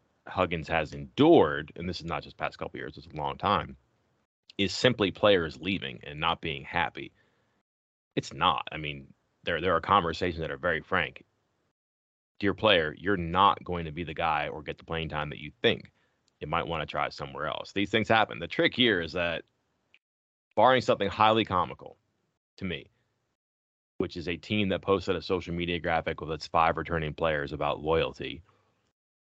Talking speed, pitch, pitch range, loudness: 185 wpm, 80 Hz, 75-95 Hz, -28 LUFS